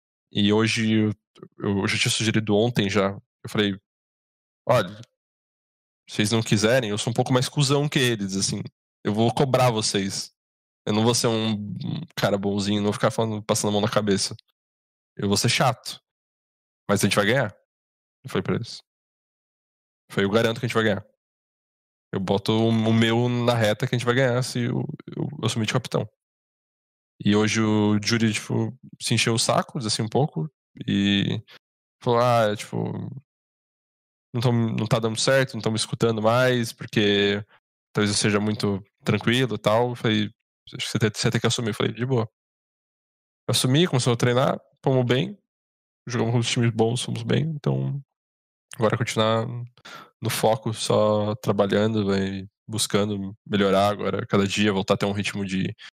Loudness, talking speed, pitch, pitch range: -23 LUFS, 175 wpm, 110 Hz, 105-120 Hz